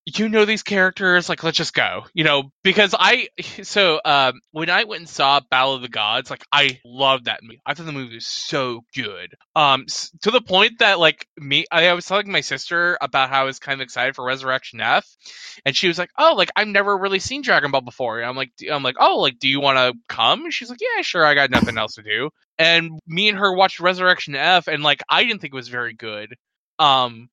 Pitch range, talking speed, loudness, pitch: 135-190 Hz, 245 wpm, -18 LUFS, 155 Hz